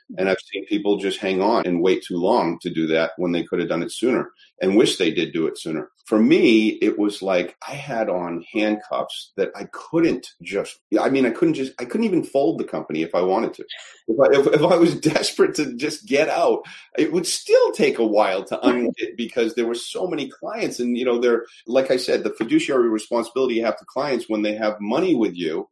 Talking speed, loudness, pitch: 235 wpm, -21 LUFS, 120 Hz